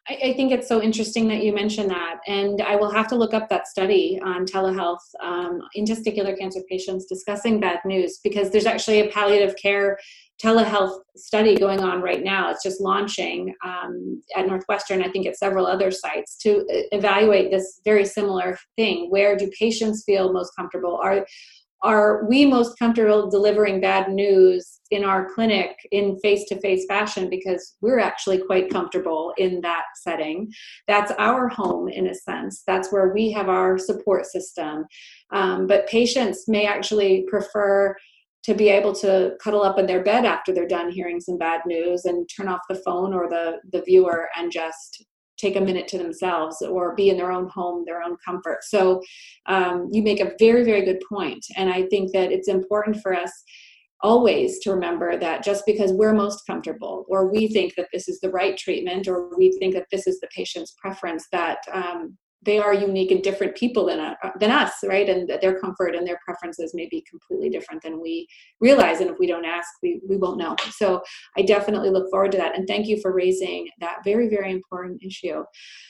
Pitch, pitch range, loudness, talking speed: 195 Hz, 185-210 Hz, -22 LUFS, 195 wpm